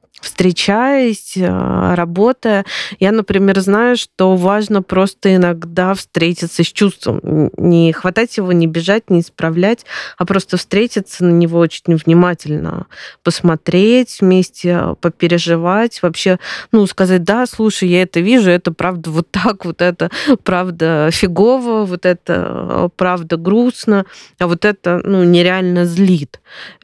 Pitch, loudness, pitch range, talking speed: 185 Hz, -14 LUFS, 175-205 Hz, 125 wpm